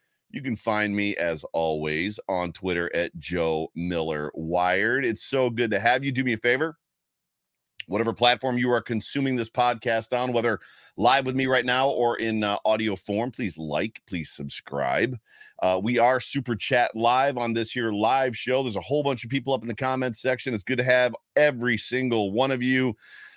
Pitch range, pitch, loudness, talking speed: 100-130 Hz, 120 Hz, -25 LUFS, 195 wpm